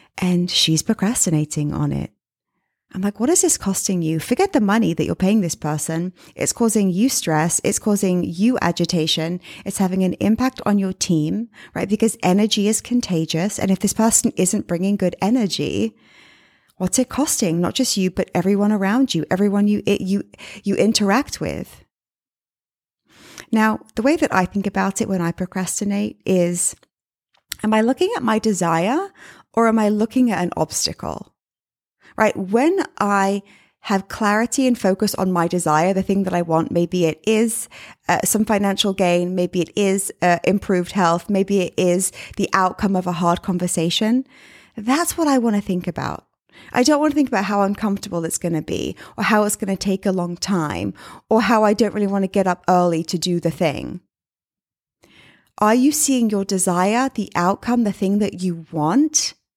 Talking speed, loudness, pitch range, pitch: 185 wpm, -19 LUFS, 180-220 Hz, 195 Hz